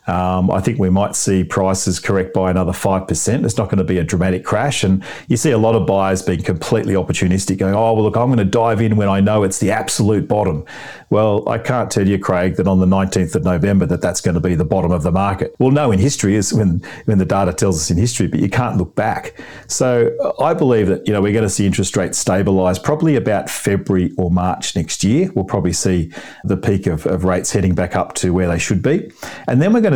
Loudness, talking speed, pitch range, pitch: -16 LUFS, 255 wpm, 95-110 Hz, 95 Hz